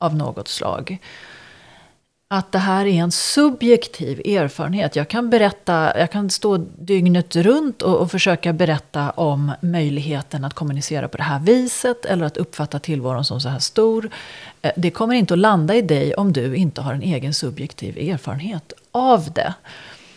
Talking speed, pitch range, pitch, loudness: 165 wpm, 150-200 Hz, 170 Hz, -19 LUFS